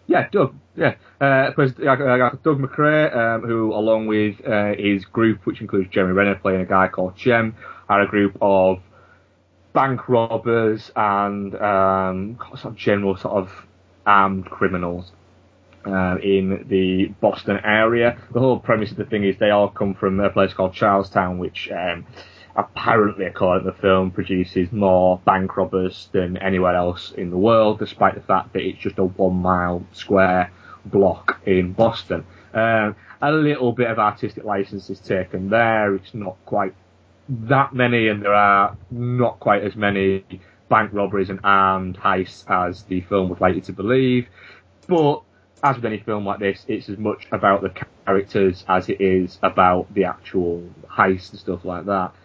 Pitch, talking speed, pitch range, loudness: 100 Hz, 165 wpm, 95-110 Hz, -20 LUFS